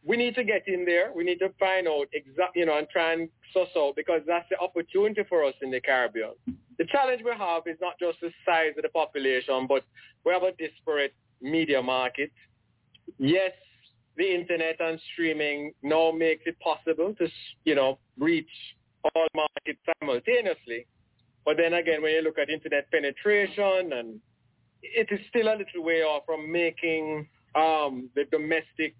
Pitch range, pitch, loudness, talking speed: 145-180 Hz, 160 Hz, -27 LUFS, 175 wpm